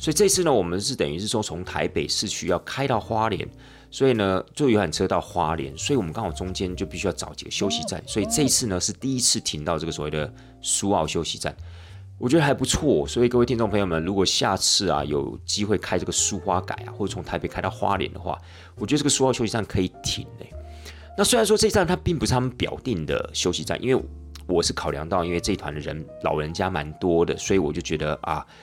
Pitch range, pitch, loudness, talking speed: 85-120 Hz, 95 Hz, -24 LUFS, 355 characters per minute